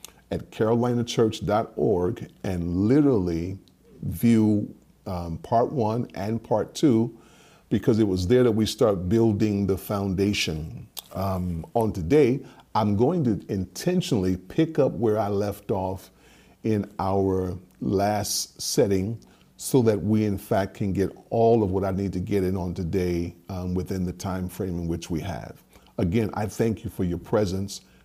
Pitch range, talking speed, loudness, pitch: 90-110 Hz, 150 wpm, -25 LUFS, 100 Hz